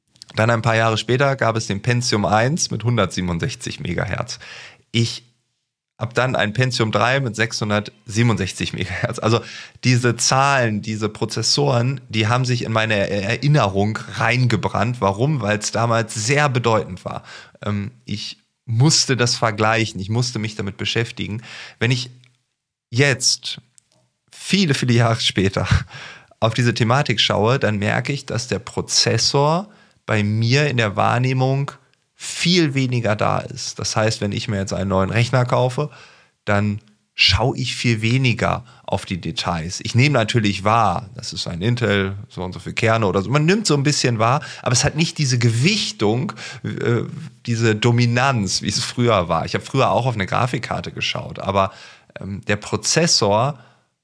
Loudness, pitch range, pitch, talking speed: -19 LUFS, 105-130 Hz, 115 Hz, 155 wpm